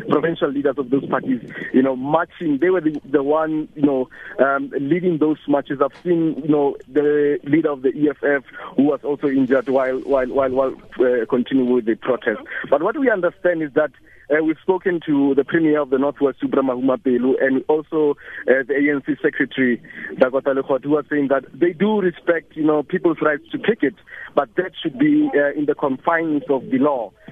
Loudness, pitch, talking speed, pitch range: -19 LUFS, 145 Hz, 200 wpm, 135-165 Hz